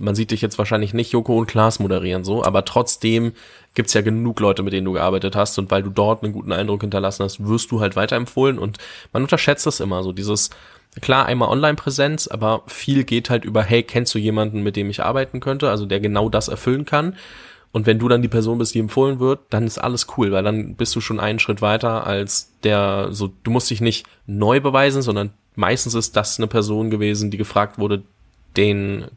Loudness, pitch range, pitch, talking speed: -19 LUFS, 100-120 Hz, 110 Hz, 220 wpm